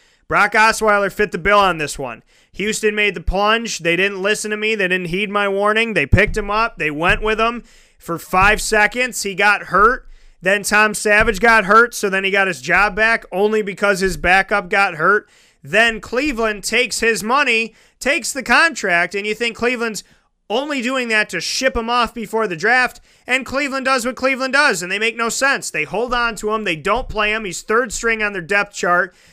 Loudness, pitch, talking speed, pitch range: -16 LUFS, 215 Hz, 210 wpm, 200-235 Hz